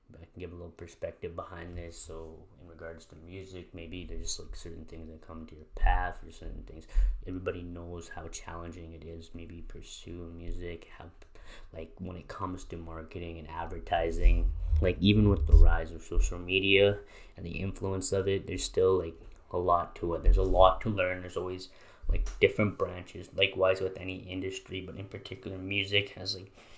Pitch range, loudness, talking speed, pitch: 80-95 Hz, -31 LUFS, 195 wpm, 85 Hz